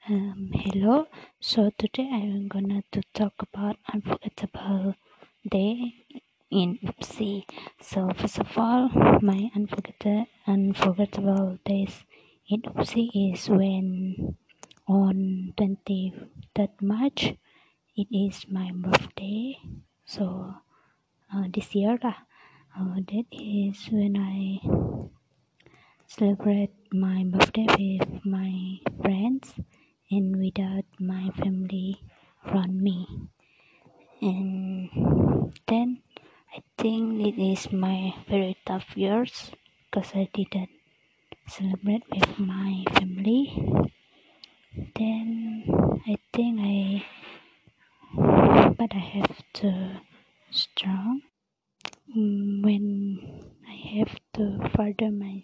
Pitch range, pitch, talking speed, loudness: 190-215 Hz, 200 Hz, 90 wpm, -26 LUFS